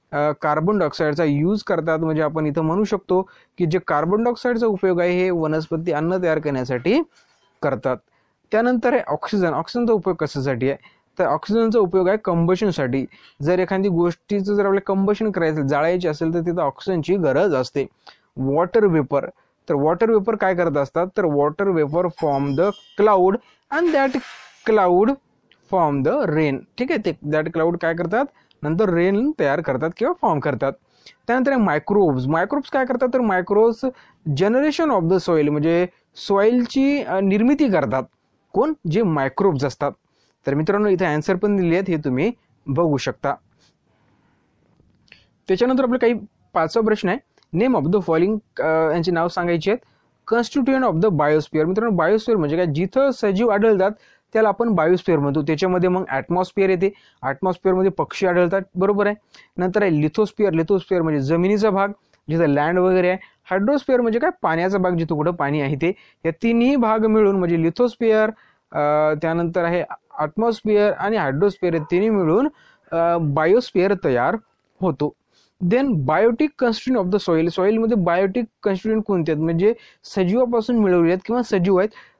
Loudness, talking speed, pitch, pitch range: -20 LUFS, 150 wpm, 185 Hz, 165-215 Hz